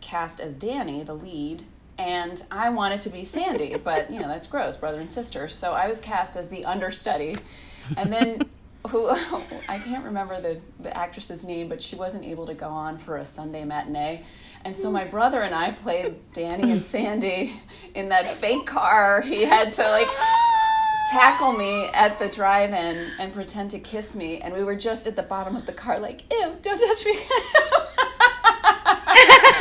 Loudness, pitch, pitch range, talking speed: -21 LUFS, 195 Hz, 175-250 Hz, 185 wpm